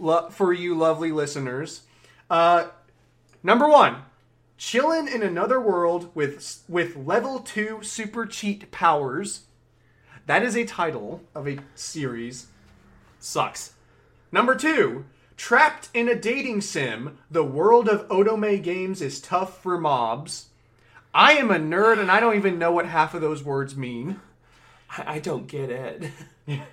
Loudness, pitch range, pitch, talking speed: -22 LUFS, 145-215 Hz, 170 Hz, 140 wpm